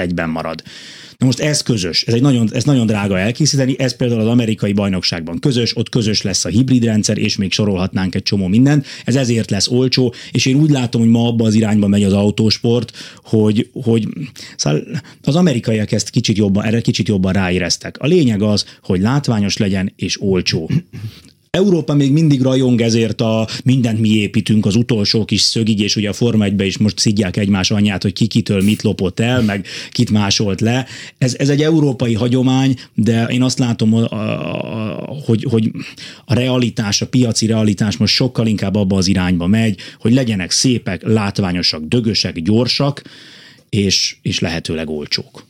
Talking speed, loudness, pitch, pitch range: 175 wpm, -15 LUFS, 110 Hz, 100-125 Hz